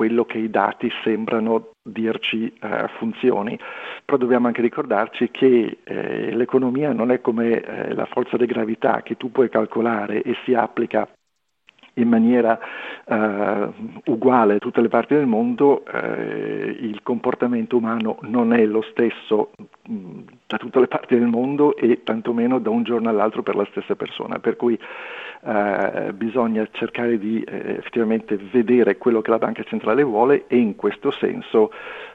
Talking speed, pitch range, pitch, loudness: 155 wpm, 110-130 Hz, 120 Hz, -21 LUFS